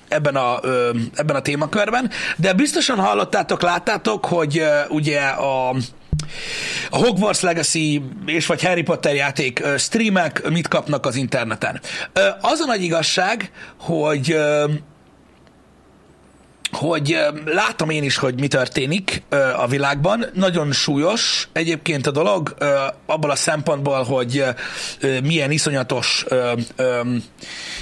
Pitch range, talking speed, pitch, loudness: 135-175 Hz, 110 wpm, 150 Hz, -19 LUFS